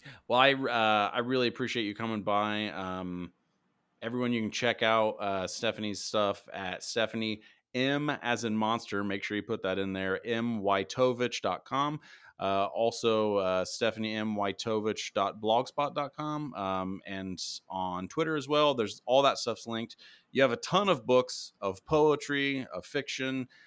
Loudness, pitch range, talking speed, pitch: -30 LUFS, 100-130 Hz, 145 wpm, 110 Hz